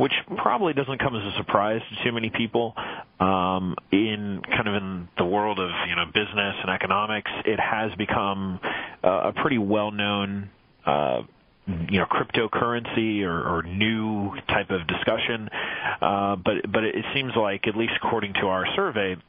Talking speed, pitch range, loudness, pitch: 165 wpm, 95-110 Hz, -25 LUFS, 100 Hz